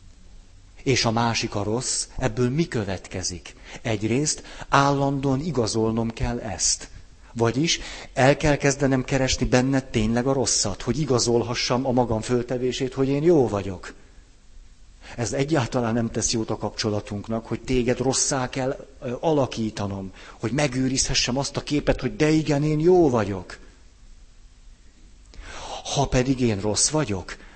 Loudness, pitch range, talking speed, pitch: -23 LUFS, 110-135 Hz, 130 wpm, 125 Hz